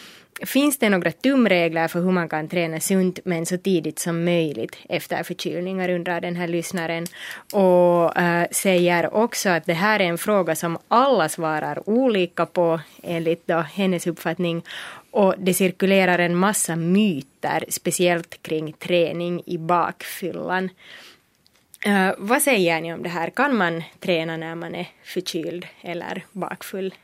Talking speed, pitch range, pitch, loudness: 150 wpm, 170-190 Hz, 175 Hz, -22 LUFS